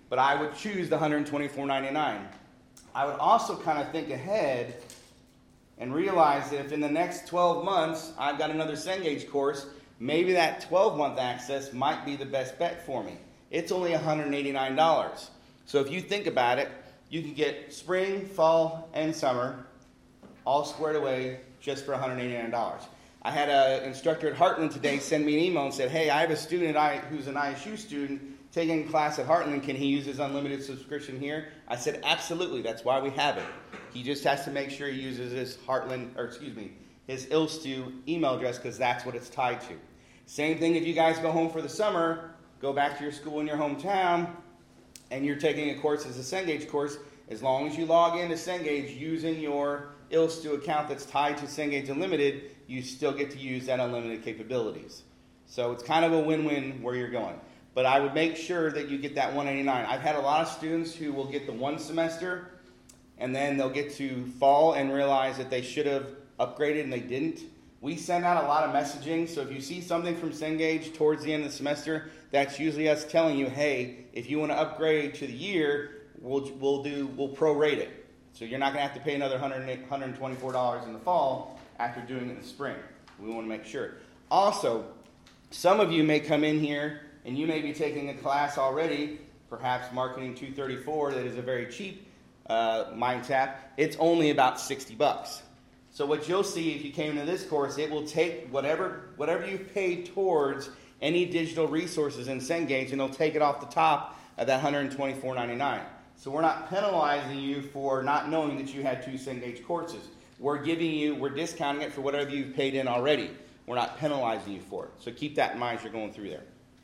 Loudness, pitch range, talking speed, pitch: -29 LUFS, 135-155 Hz, 205 wpm, 145 Hz